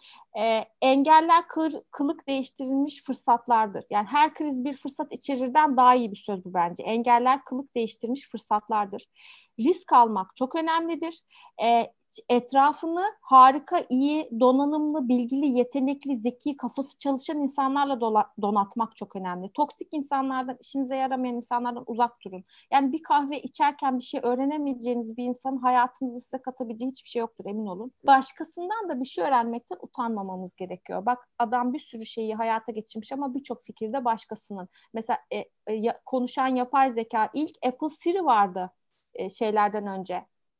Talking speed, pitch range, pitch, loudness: 140 wpm, 230-285 Hz, 255 Hz, -26 LUFS